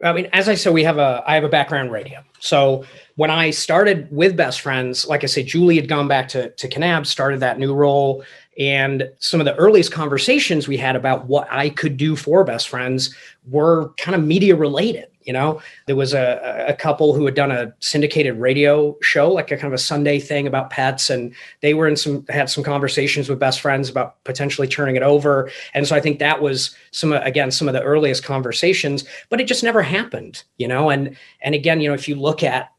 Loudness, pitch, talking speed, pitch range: -18 LUFS, 145 Hz, 225 wpm, 135-155 Hz